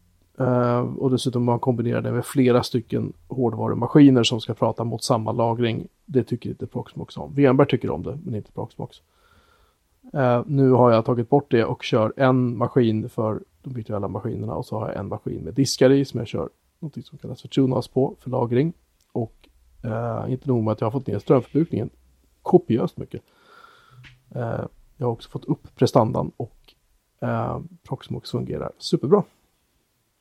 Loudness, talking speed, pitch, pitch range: -22 LUFS, 180 wpm, 125 Hz, 115-130 Hz